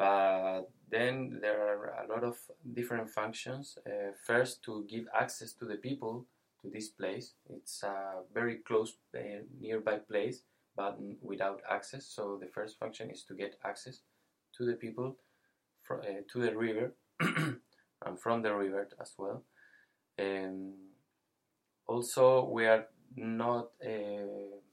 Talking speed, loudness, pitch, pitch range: 135 wpm, -36 LUFS, 110 Hz, 100-120 Hz